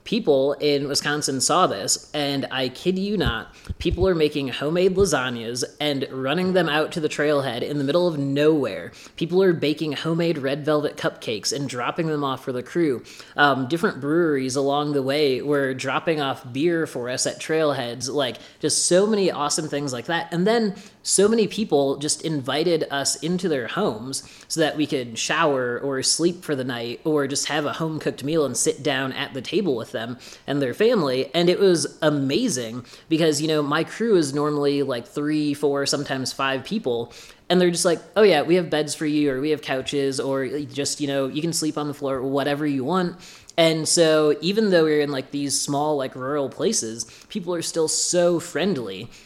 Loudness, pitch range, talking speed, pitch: -22 LUFS, 140-165 Hz, 200 wpm, 150 Hz